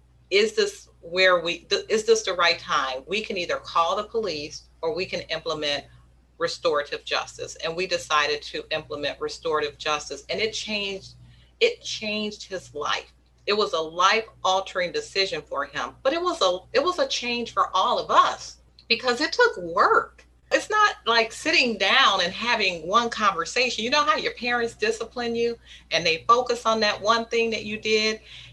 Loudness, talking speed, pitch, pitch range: -23 LUFS, 180 wpm, 220 Hz, 175-290 Hz